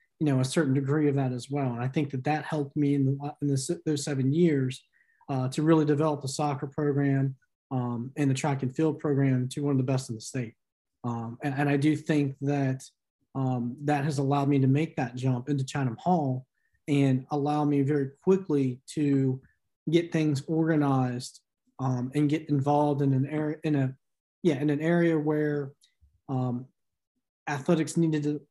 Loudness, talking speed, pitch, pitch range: -28 LUFS, 190 wpm, 145 Hz, 130-150 Hz